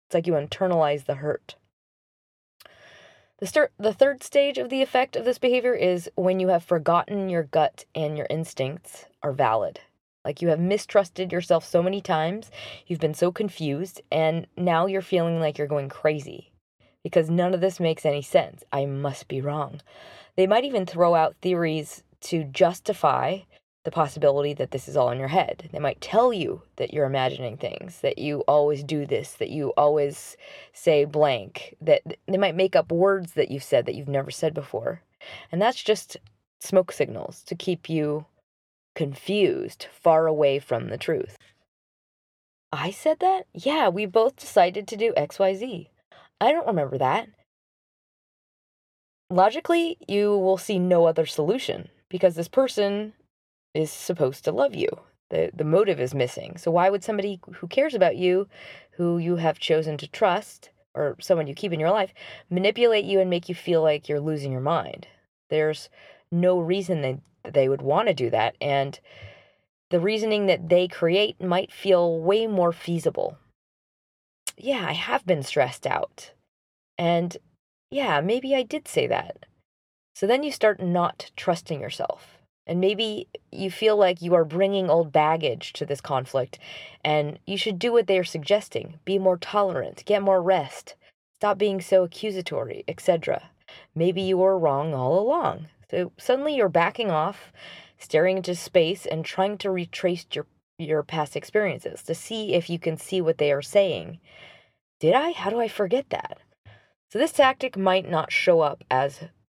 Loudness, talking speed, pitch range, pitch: -24 LUFS, 170 wpm, 155-205 Hz, 180 Hz